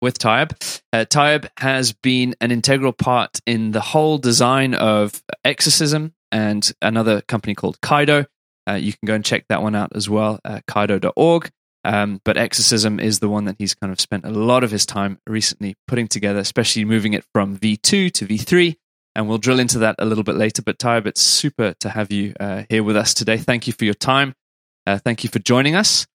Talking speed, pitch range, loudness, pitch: 210 wpm, 105-130 Hz, -18 LUFS, 110 Hz